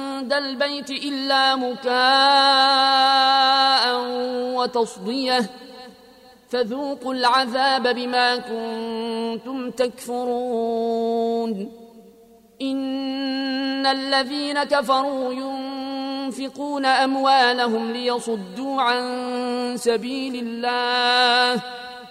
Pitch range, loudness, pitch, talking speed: 245-270 Hz, -21 LUFS, 250 Hz, 50 wpm